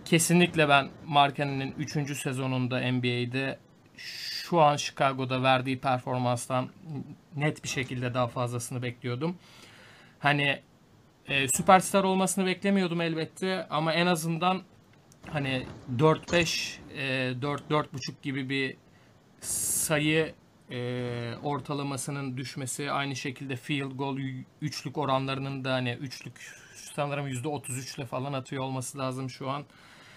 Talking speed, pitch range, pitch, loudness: 105 wpm, 130-150 Hz, 140 Hz, -29 LUFS